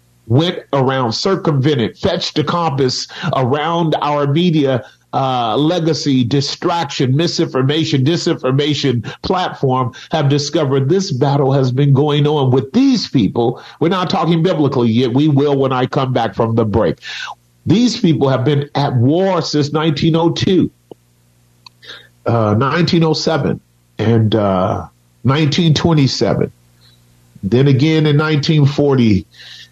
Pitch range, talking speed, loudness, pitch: 120-160 Hz, 115 wpm, -15 LUFS, 140 Hz